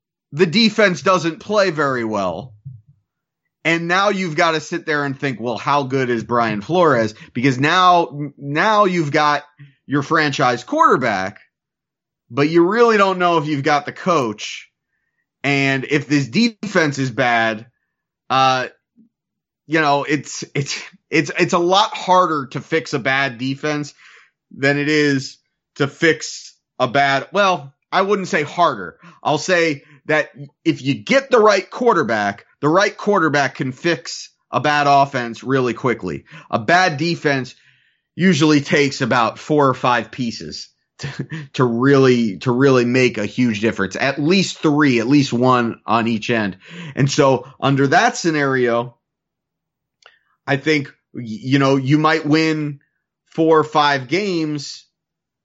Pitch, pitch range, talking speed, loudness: 145 Hz, 130-165 Hz, 145 wpm, -17 LUFS